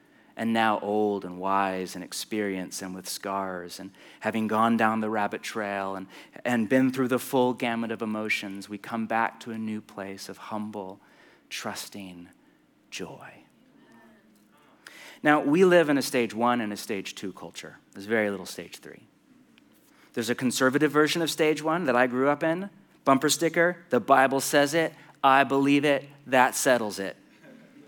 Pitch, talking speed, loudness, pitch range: 115 Hz, 170 wpm, -26 LUFS, 100-135 Hz